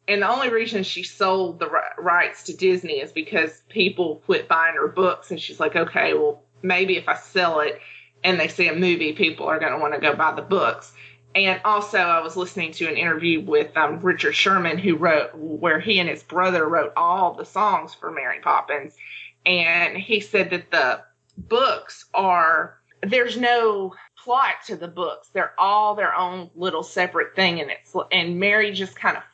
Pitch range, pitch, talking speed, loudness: 165-200 Hz, 180 Hz, 195 wpm, -21 LUFS